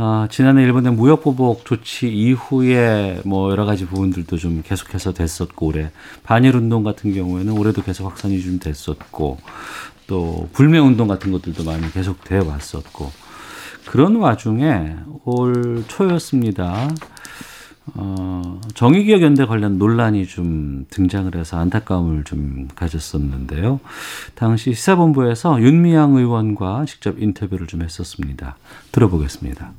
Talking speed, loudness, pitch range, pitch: 300 characters per minute, -17 LUFS, 85-125 Hz, 100 Hz